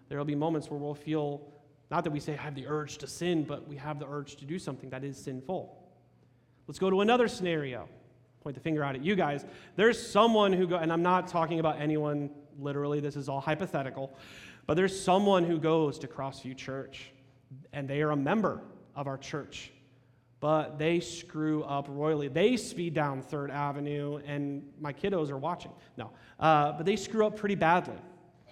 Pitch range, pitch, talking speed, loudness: 140-170 Hz, 150 Hz, 195 wpm, -31 LUFS